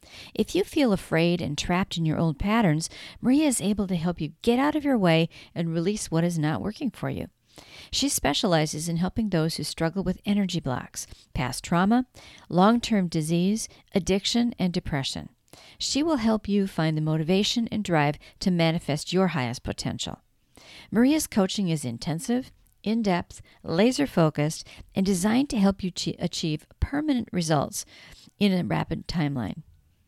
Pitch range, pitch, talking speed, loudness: 160-220 Hz, 185 Hz, 160 wpm, -26 LUFS